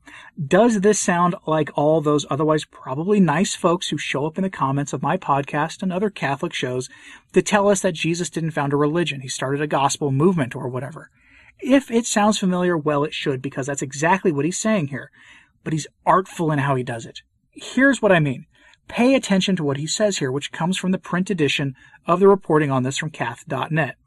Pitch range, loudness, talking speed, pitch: 140-190 Hz, -20 LUFS, 210 wpm, 160 Hz